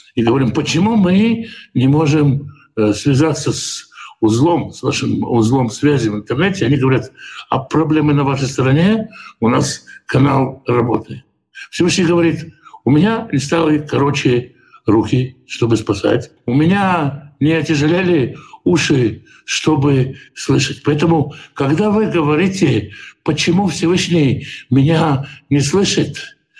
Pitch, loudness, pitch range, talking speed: 150 Hz, -15 LUFS, 135-170 Hz, 115 wpm